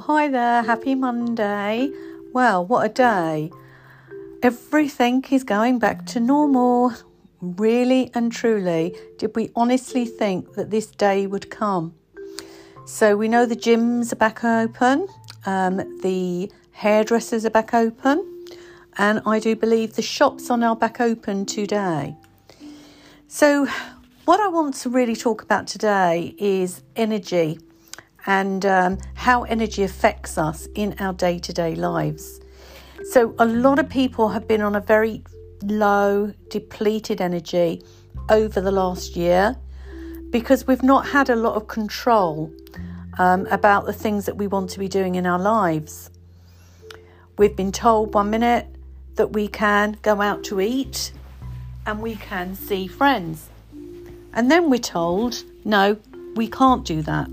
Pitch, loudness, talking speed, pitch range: 210 Hz, -20 LUFS, 145 wpm, 180-240 Hz